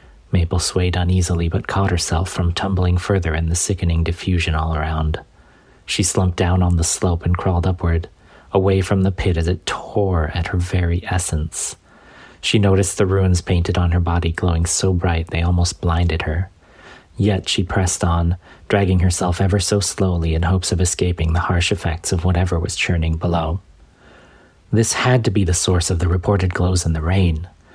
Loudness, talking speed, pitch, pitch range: -19 LUFS, 180 wpm, 90 Hz, 85-95 Hz